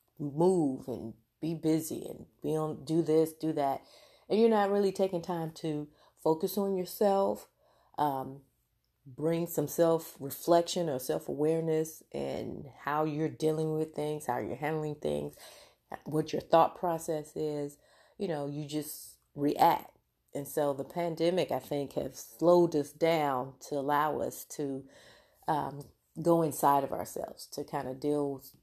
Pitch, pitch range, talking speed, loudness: 150 Hz, 140-165 Hz, 155 wpm, -32 LUFS